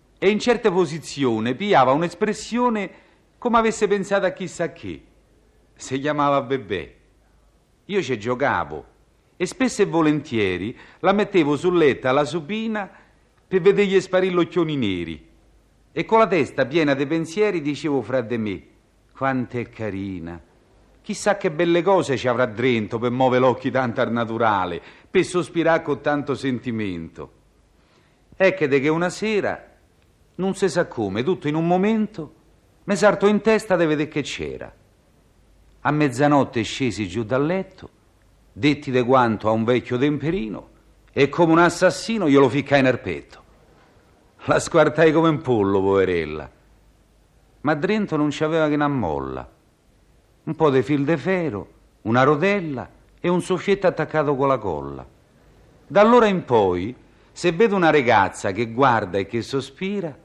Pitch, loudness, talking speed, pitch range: 150 Hz, -21 LUFS, 150 wpm, 125-185 Hz